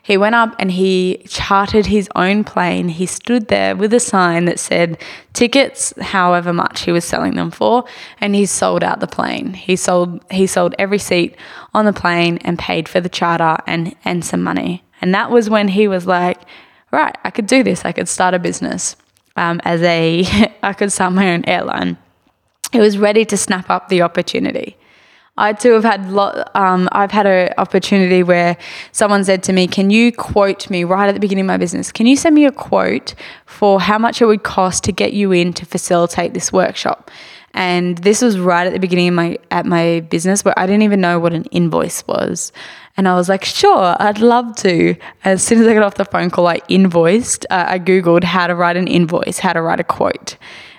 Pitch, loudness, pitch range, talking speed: 185 Hz, -14 LUFS, 175-210 Hz, 215 wpm